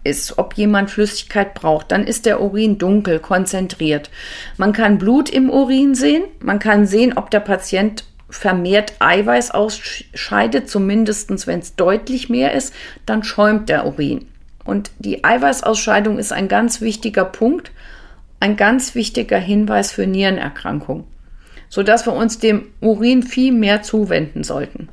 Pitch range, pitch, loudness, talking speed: 195-230 Hz, 210 Hz, -16 LUFS, 145 wpm